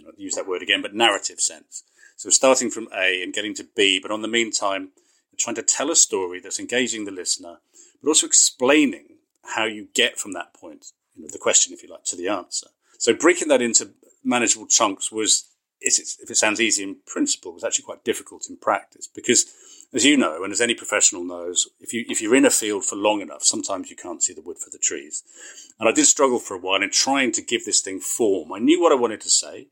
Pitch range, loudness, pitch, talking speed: 265-385 Hz, -20 LUFS, 315 Hz, 240 wpm